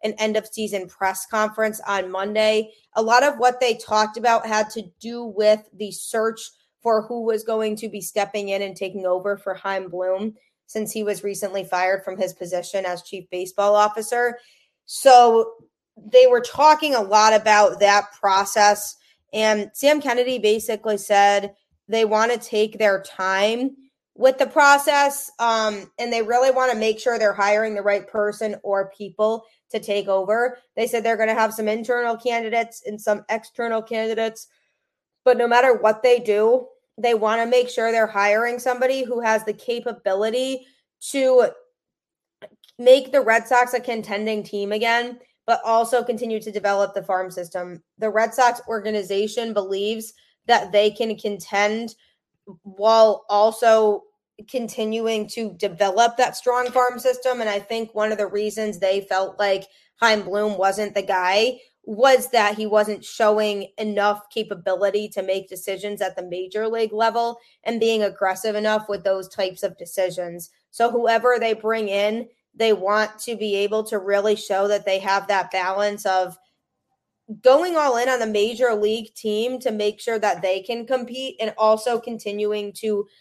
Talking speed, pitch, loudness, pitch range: 165 wpm, 215 Hz, -21 LUFS, 205-235 Hz